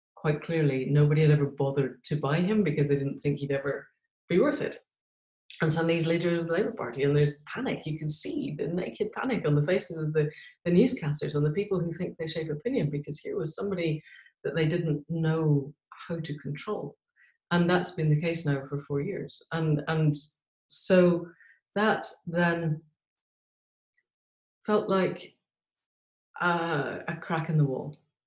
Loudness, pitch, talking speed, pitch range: -28 LUFS, 155 Hz, 175 wpm, 145-170 Hz